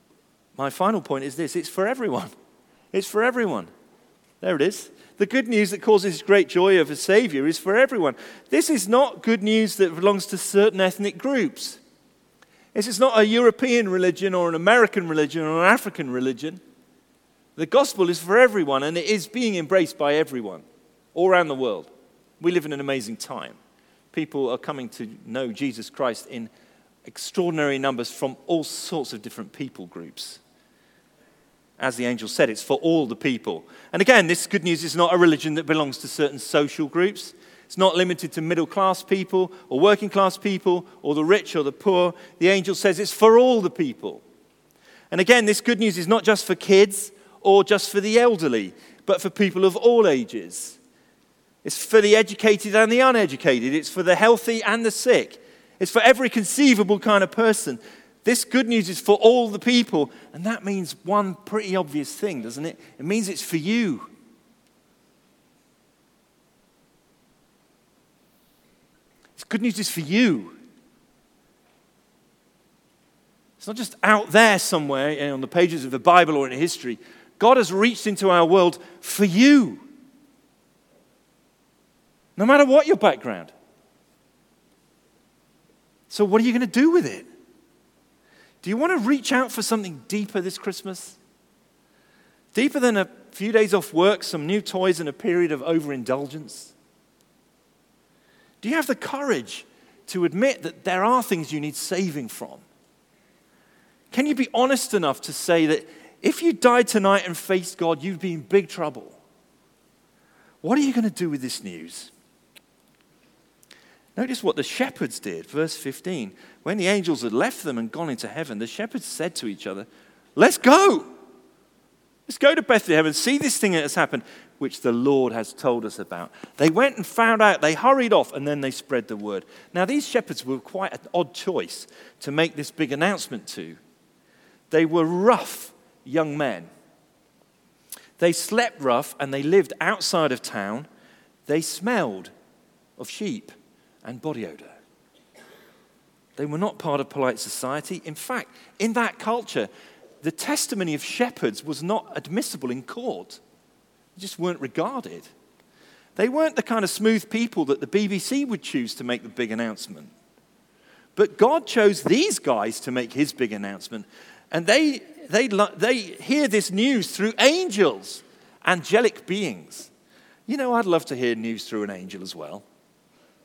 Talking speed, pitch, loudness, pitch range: 165 wpm, 195 Hz, -21 LUFS, 155-230 Hz